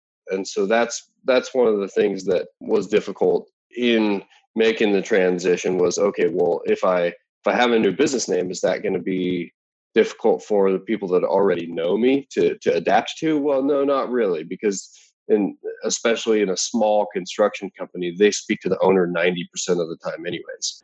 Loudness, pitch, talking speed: -21 LUFS, 120 Hz, 190 wpm